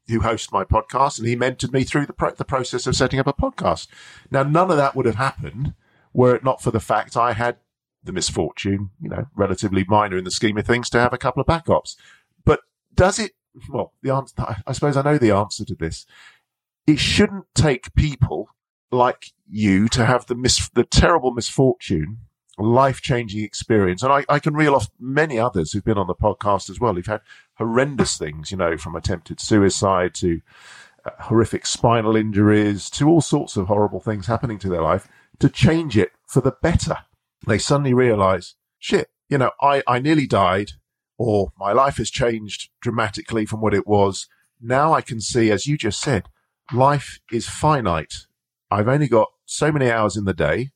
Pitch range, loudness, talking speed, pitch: 100-135 Hz, -20 LUFS, 195 wpm, 115 Hz